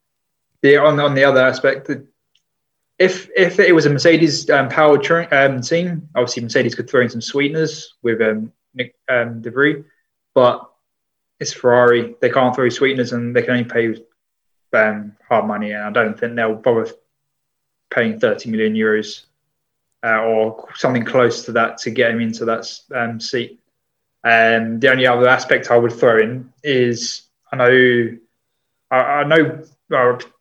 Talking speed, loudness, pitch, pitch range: 165 wpm, -16 LUFS, 125 Hz, 115-150 Hz